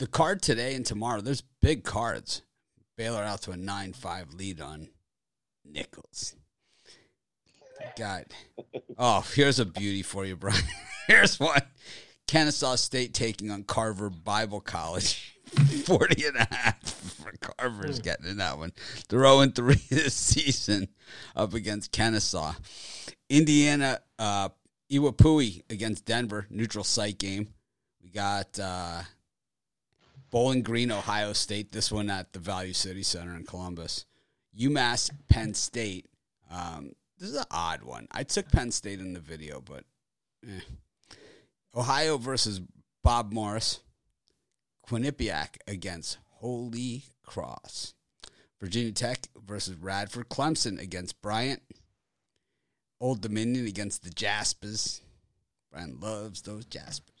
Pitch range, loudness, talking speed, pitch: 95-120 Hz, -28 LUFS, 120 wpm, 105 Hz